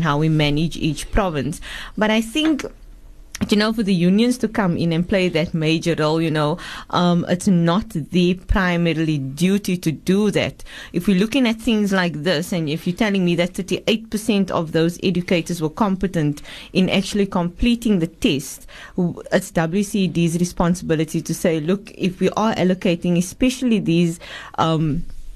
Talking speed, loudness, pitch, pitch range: 165 wpm, -20 LUFS, 180 Hz, 165-200 Hz